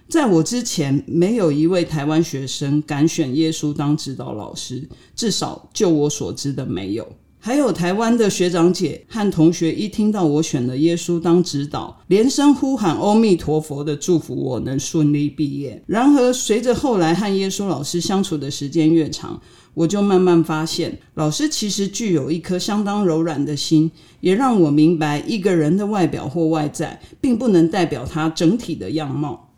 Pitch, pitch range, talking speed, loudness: 165 Hz, 150-195 Hz, 270 characters per minute, -19 LUFS